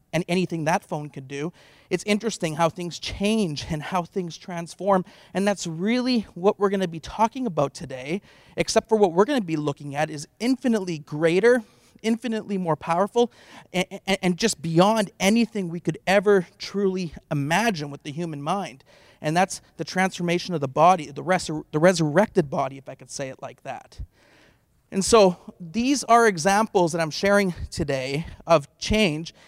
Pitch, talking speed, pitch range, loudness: 180 Hz, 165 wpm, 160-205 Hz, -23 LUFS